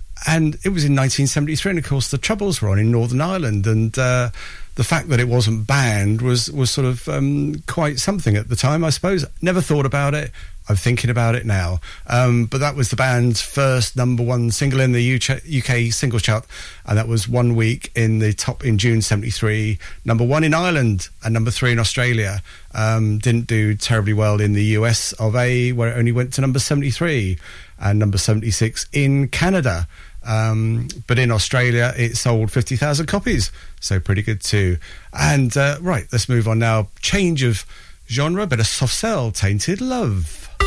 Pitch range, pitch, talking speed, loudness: 110-135 Hz, 120 Hz, 195 wpm, -18 LUFS